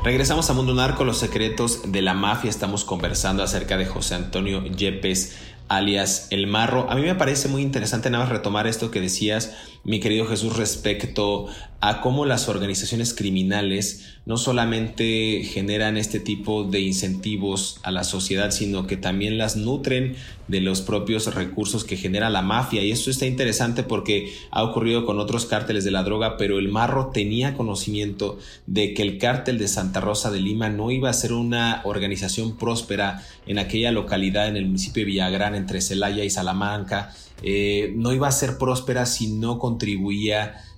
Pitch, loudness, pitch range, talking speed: 105 Hz, -23 LUFS, 100-115 Hz, 175 wpm